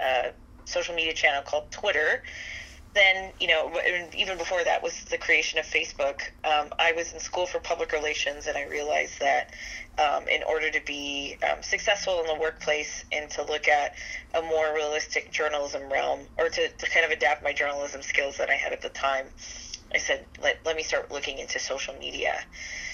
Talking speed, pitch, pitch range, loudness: 190 wpm, 155 Hz, 150-175 Hz, -26 LUFS